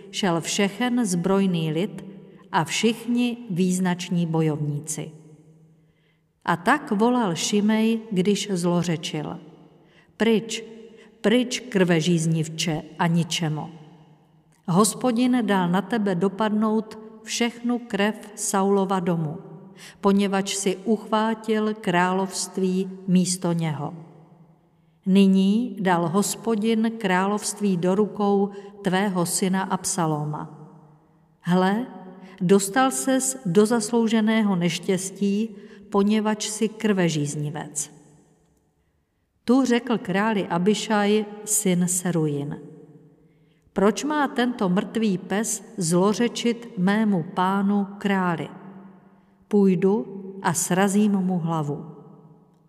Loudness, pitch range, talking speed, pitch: -23 LUFS, 165-210 Hz, 85 wpm, 190 Hz